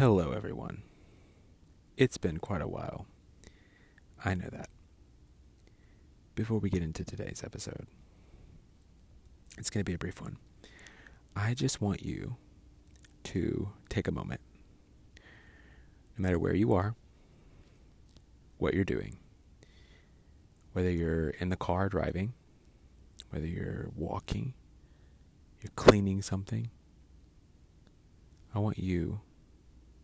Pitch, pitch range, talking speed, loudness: 85 Hz, 75-100 Hz, 110 wpm, -33 LUFS